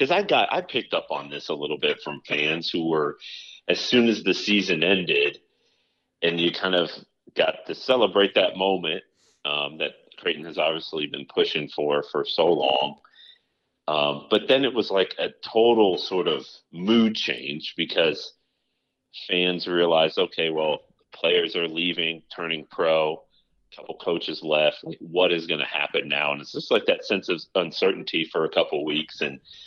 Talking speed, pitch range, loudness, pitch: 175 wpm, 80-115 Hz, -24 LUFS, 90 Hz